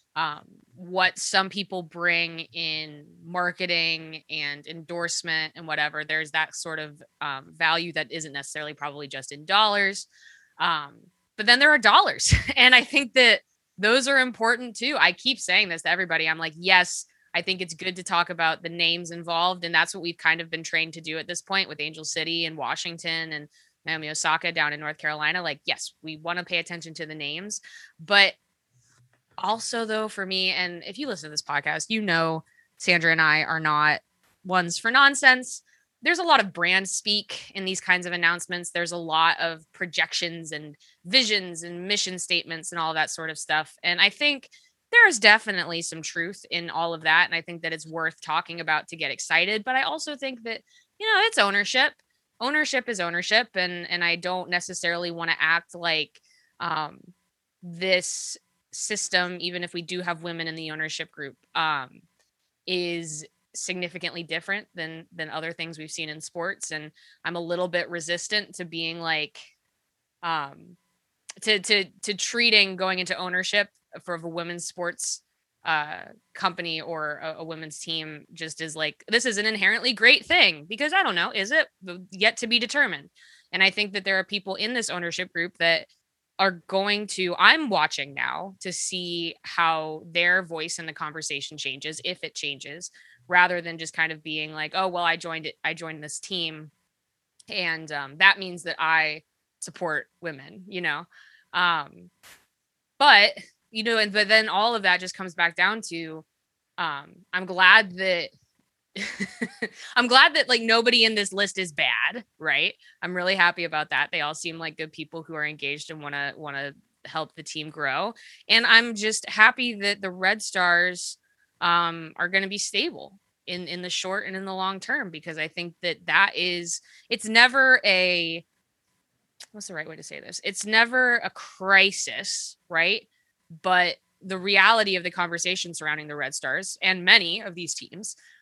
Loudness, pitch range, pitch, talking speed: -23 LUFS, 160-195 Hz, 175 Hz, 185 wpm